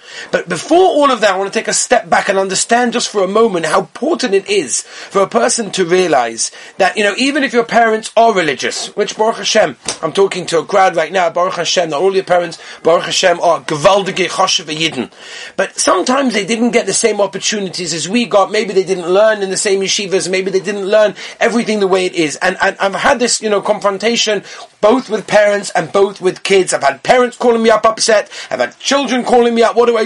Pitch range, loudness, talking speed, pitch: 185-230 Hz, -13 LUFS, 230 wpm, 200 Hz